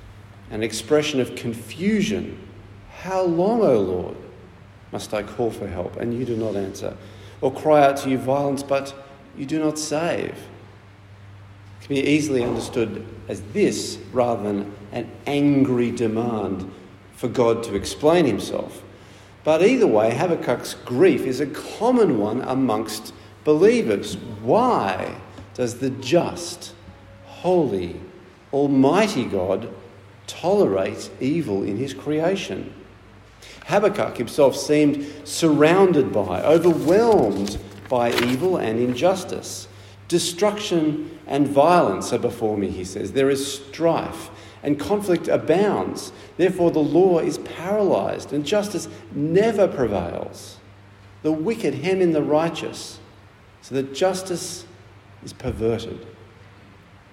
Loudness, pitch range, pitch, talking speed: -21 LUFS, 100-150 Hz, 120 Hz, 120 wpm